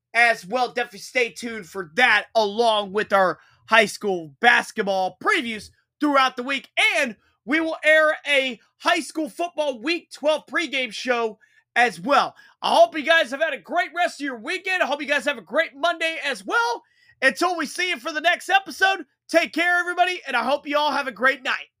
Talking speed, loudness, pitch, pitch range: 200 wpm, -21 LUFS, 285 Hz, 235-330 Hz